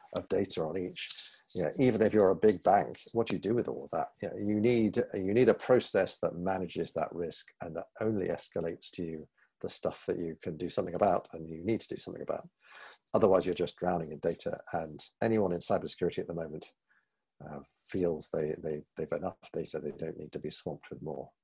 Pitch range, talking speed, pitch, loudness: 85-110 Hz, 225 wpm, 100 Hz, -33 LUFS